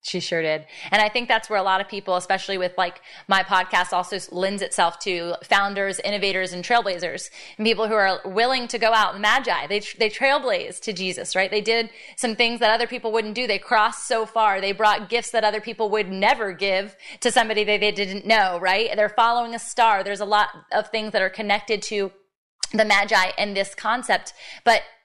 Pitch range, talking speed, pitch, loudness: 195-225 Hz, 215 wpm, 210 Hz, -22 LUFS